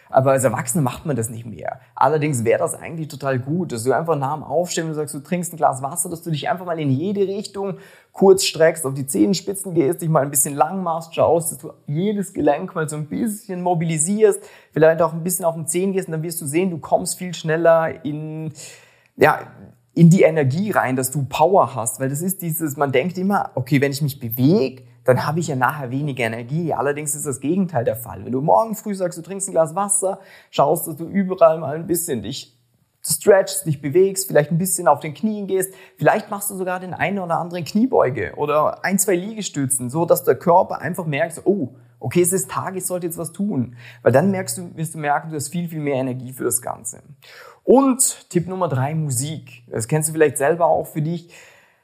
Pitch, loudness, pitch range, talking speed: 160 Hz, -20 LUFS, 140-185 Hz, 225 wpm